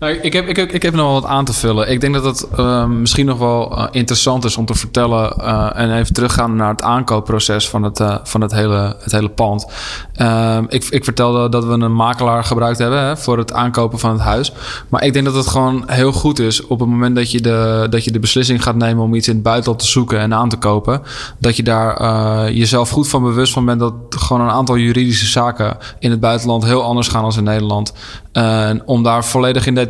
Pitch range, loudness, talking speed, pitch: 110-125 Hz, -14 LUFS, 245 wpm, 120 Hz